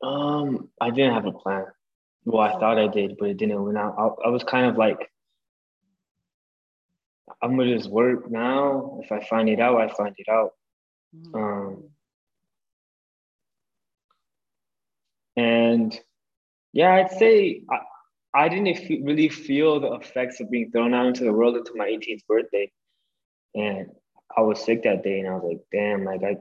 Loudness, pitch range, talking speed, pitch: -23 LUFS, 100-140 Hz, 165 wpm, 115 Hz